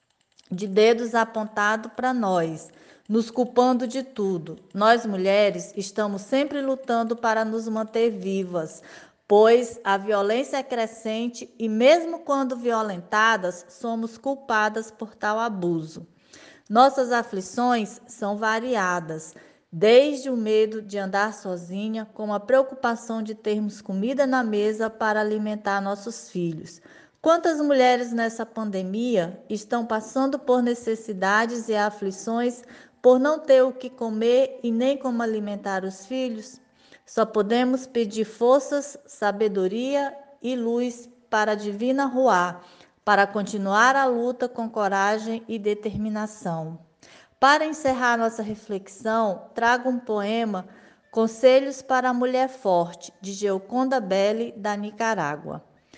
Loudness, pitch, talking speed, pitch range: -24 LUFS, 225 Hz, 120 wpm, 205-250 Hz